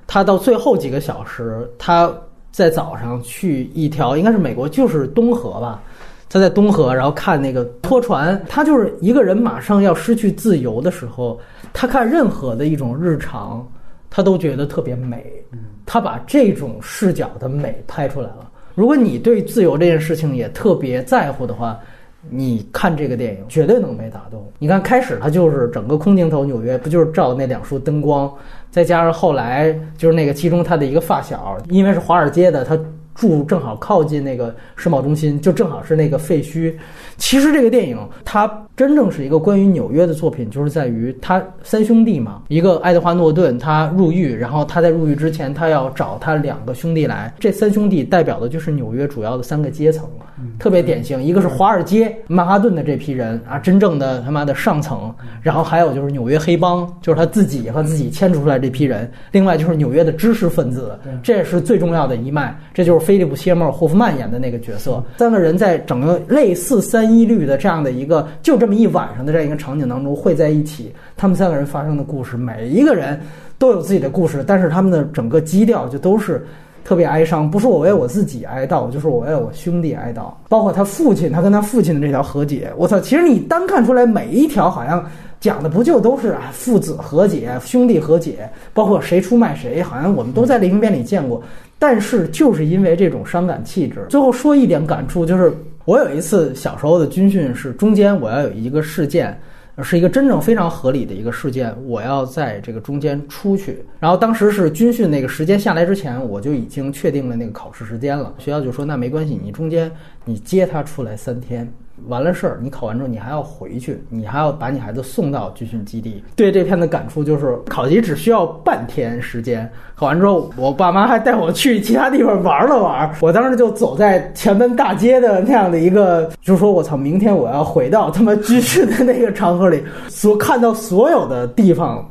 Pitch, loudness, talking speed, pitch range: 165 Hz, -15 LUFS, 320 characters per minute, 135-195 Hz